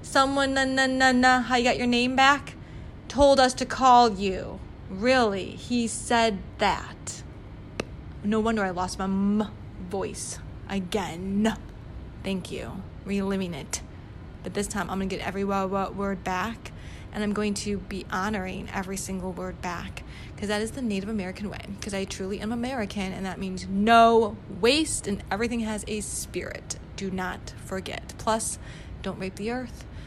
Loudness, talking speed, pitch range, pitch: -26 LUFS, 170 wpm, 190-235 Hz, 205 Hz